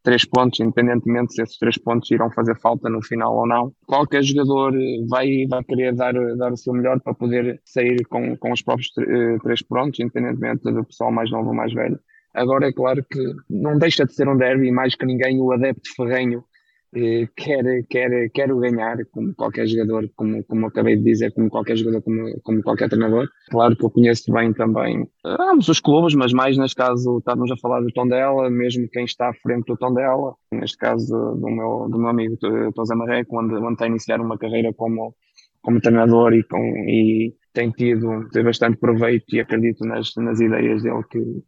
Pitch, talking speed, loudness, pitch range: 120 Hz, 200 wpm, -20 LUFS, 115-125 Hz